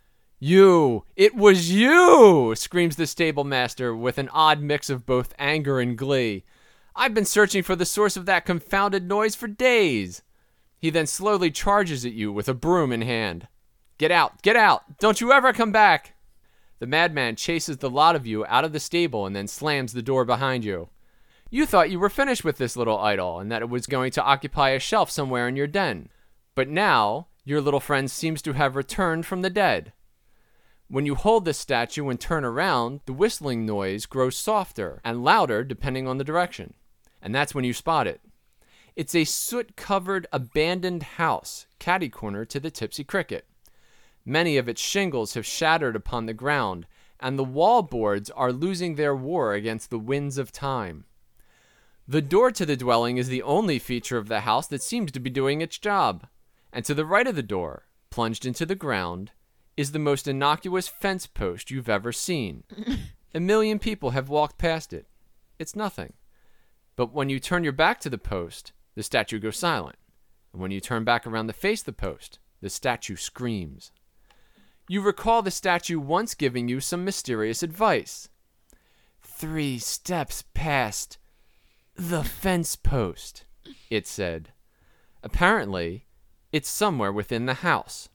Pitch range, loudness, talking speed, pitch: 120-180 Hz, -23 LUFS, 175 wpm, 145 Hz